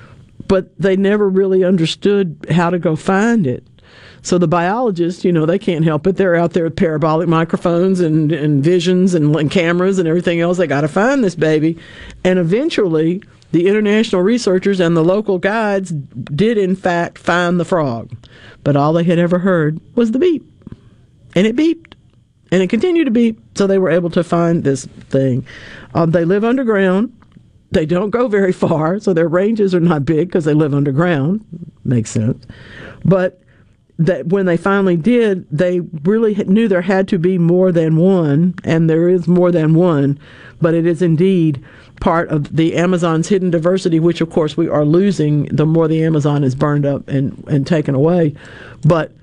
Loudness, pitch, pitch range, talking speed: -15 LUFS, 170 Hz, 155-190 Hz, 185 wpm